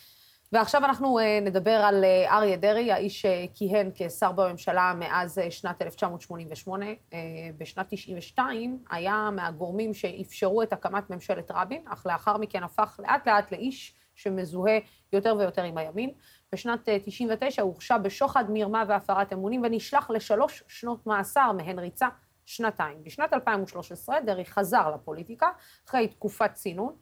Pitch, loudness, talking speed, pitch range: 205 Hz, -27 LUFS, 125 wpm, 185-225 Hz